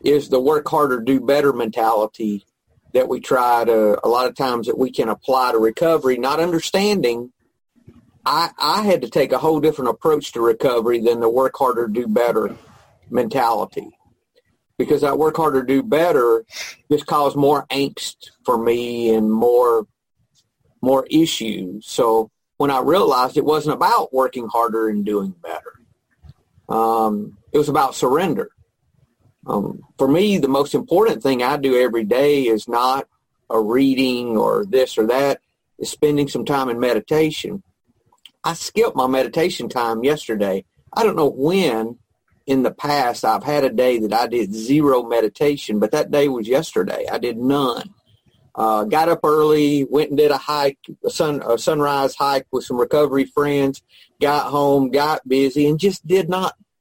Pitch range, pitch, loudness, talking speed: 120-150 Hz, 135 Hz, -18 LUFS, 165 wpm